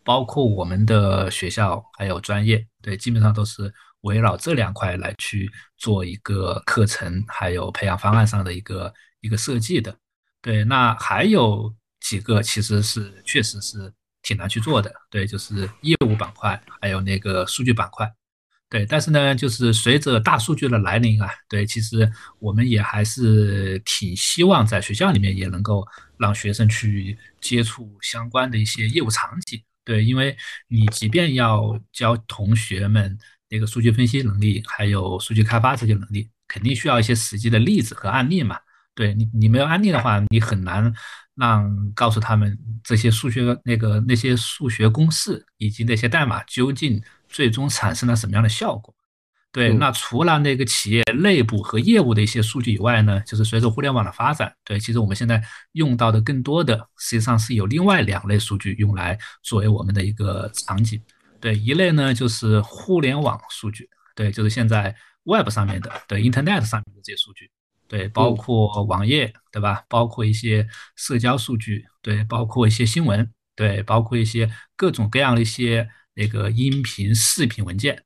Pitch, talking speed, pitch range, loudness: 110 Hz, 280 characters per minute, 105-120 Hz, -20 LUFS